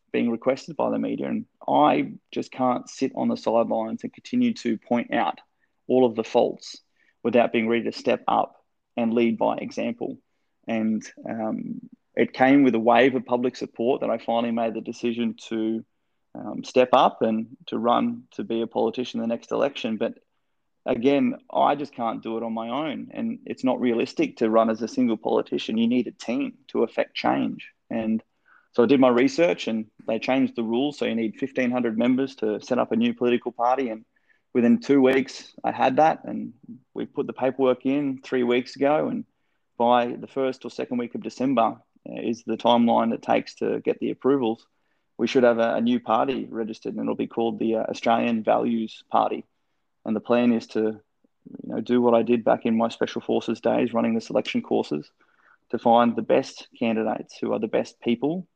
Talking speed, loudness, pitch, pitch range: 200 wpm, -24 LUFS, 120 Hz, 115-130 Hz